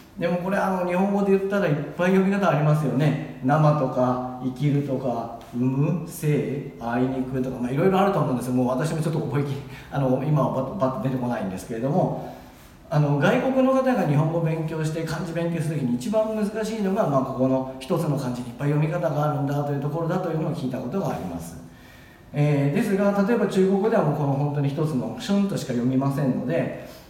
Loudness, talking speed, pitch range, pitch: -24 LUFS, 445 characters per minute, 130-175 Hz, 145 Hz